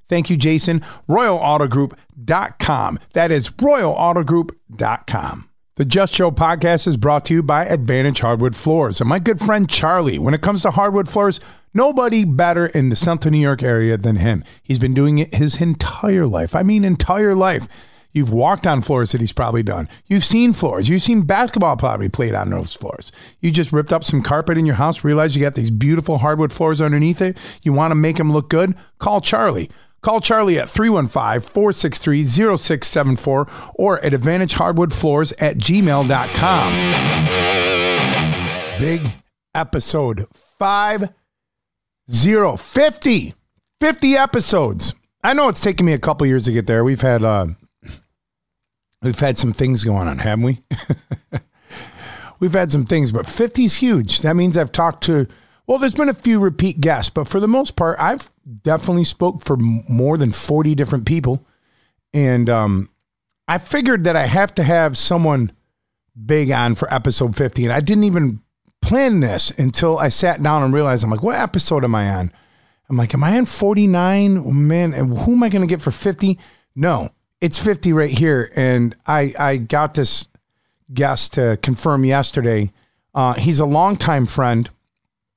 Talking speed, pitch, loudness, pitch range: 165 wpm, 150 Hz, -16 LUFS, 125-180 Hz